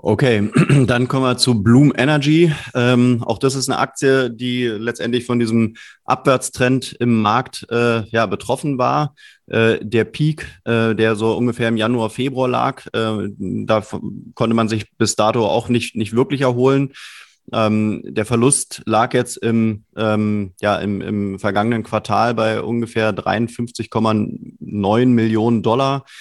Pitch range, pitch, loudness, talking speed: 110-125 Hz, 115 Hz, -17 LUFS, 150 wpm